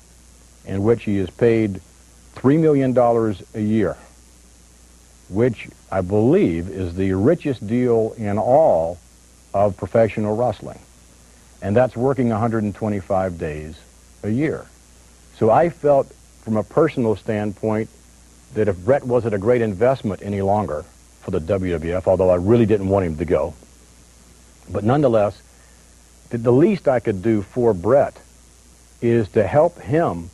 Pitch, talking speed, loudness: 95 Hz, 135 wpm, -19 LUFS